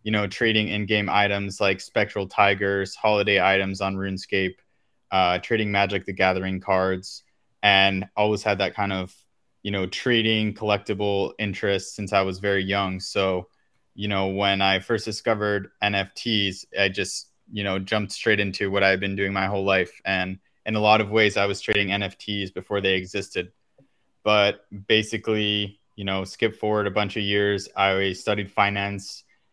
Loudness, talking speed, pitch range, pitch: -23 LUFS, 170 wpm, 95-105 Hz, 100 Hz